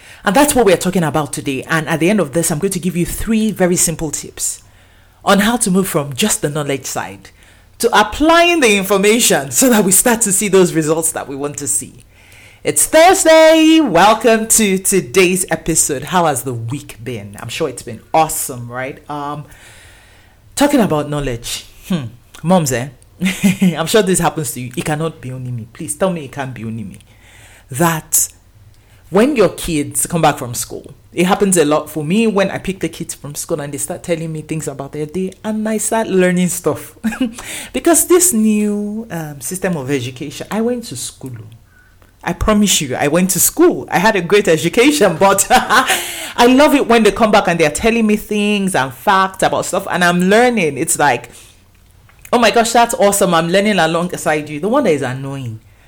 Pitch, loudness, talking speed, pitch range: 165 Hz, -14 LUFS, 200 wpm, 130-205 Hz